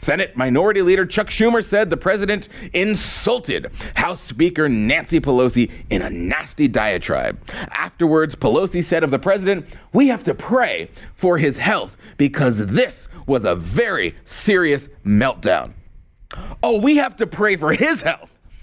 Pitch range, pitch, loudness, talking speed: 145-215 Hz, 185 Hz, -18 LUFS, 145 wpm